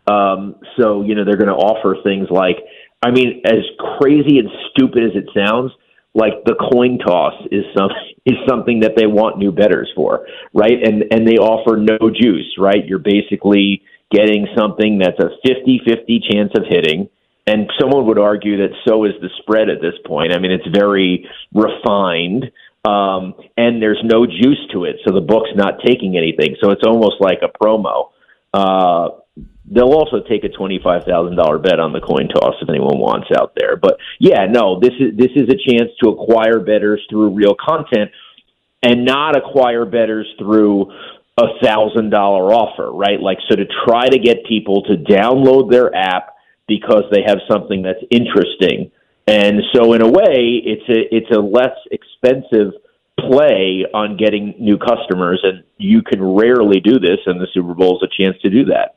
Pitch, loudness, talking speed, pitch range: 105 Hz, -14 LUFS, 180 wpm, 100-120 Hz